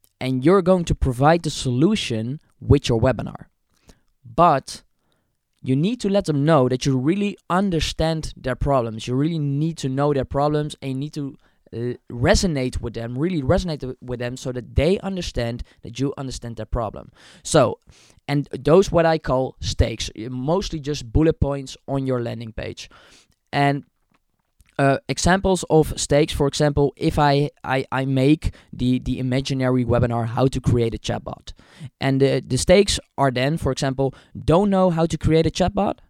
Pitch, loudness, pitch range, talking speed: 135 Hz, -21 LUFS, 125-160 Hz, 170 wpm